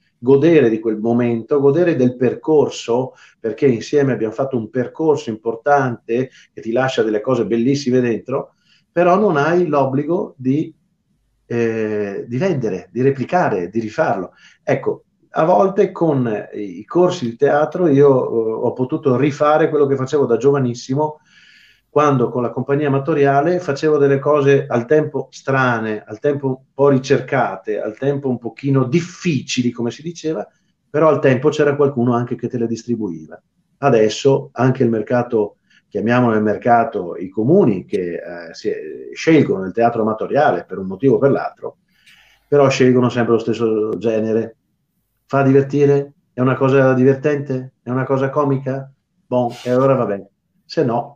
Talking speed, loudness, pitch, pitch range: 150 wpm, -17 LUFS, 135 Hz, 120-150 Hz